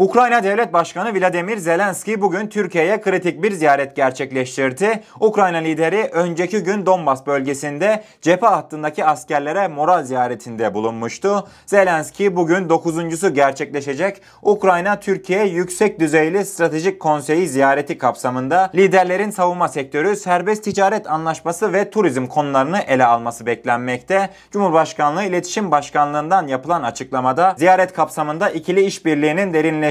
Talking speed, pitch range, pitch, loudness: 115 wpm, 150-195 Hz, 170 Hz, -17 LUFS